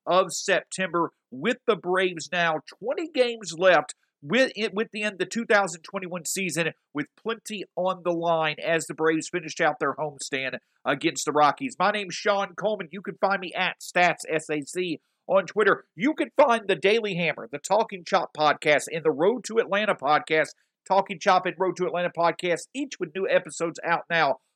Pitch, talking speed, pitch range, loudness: 180 Hz, 180 wpm, 165-205 Hz, -25 LUFS